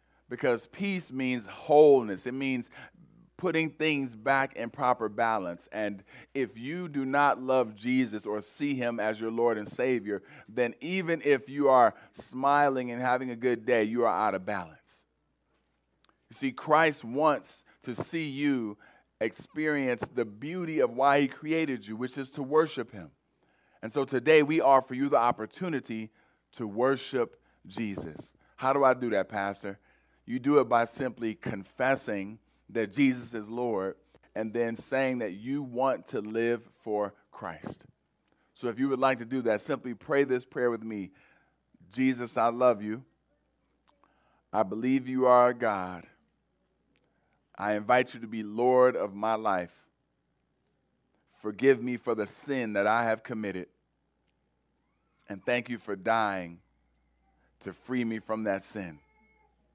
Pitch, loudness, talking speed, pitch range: 125 Hz, -29 LUFS, 155 wpm, 110-135 Hz